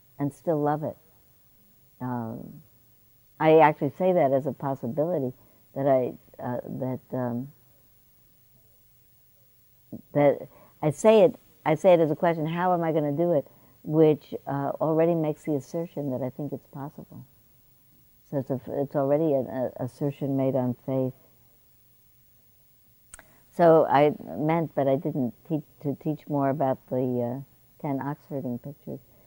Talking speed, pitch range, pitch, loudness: 150 wpm, 125-150 Hz, 135 Hz, -26 LUFS